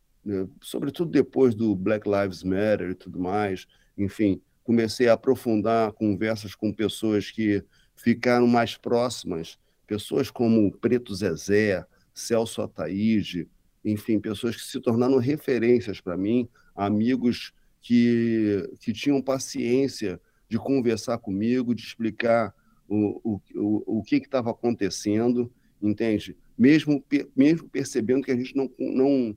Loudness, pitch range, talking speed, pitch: -25 LUFS, 105-125 Hz, 125 wpm, 110 Hz